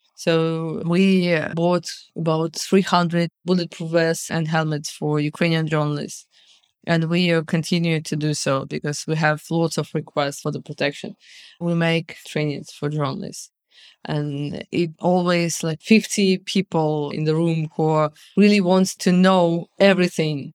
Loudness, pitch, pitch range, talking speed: -21 LUFS, 165 Hz, 155-180 Hz, 135 wpm